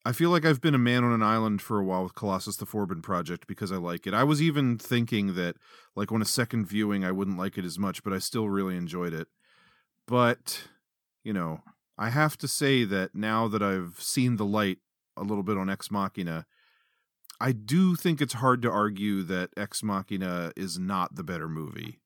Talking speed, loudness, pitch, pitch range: 215 wpm, -28 LUFS, 105 Hz, 95-120 Hz